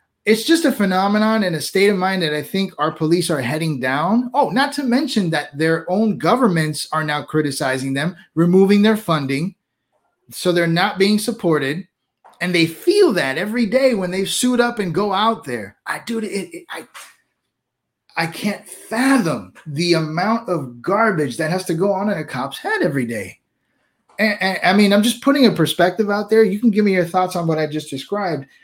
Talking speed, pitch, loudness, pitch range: 200 wpm, 190 Hz, -18 LUFS, 160-220 Hz